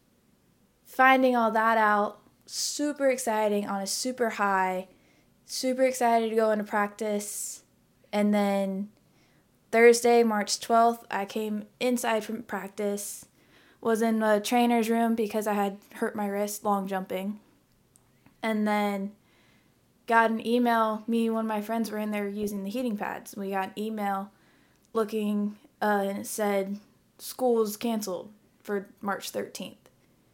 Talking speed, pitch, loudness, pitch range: 140 wpm, 215 Hz, -27 LUFS, 205-230 Hz